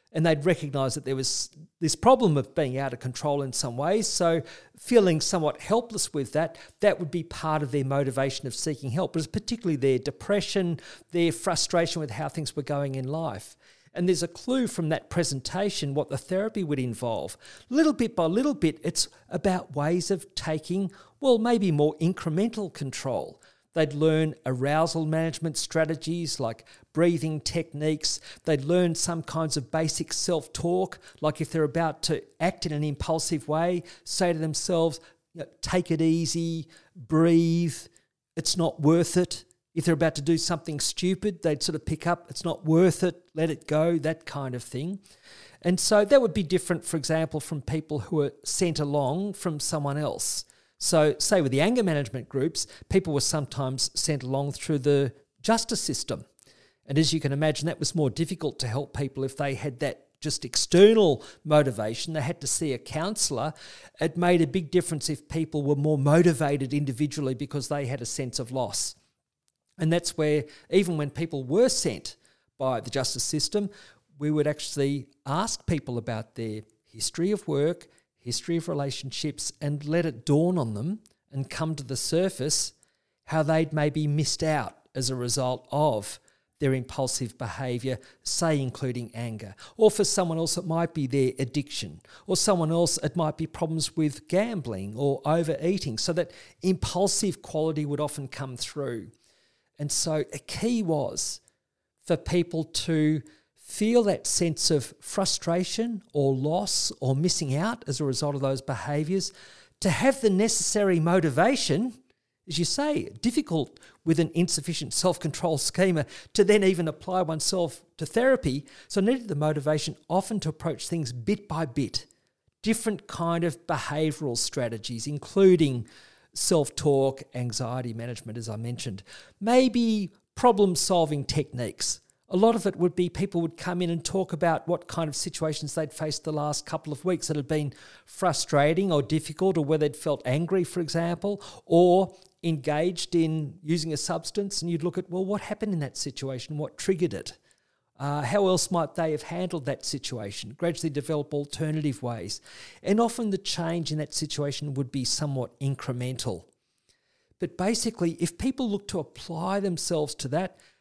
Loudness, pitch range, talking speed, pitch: -27 LUFS, 140-175 Hz, 170 wpm, 160 Hz